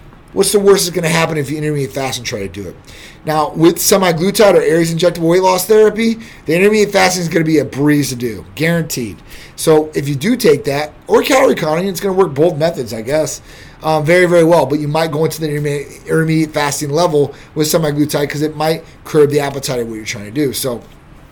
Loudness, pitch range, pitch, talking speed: -14 LUFS, 145-175 Hz, 155 Hz, 230 wpm